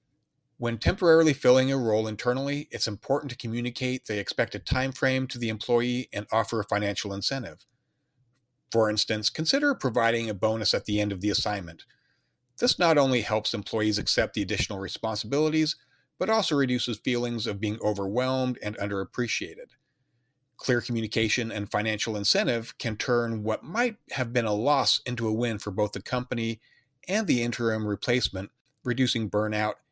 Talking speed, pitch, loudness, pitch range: 155 wpm, 115 Hz, -27 LUFS, 105-130 Hz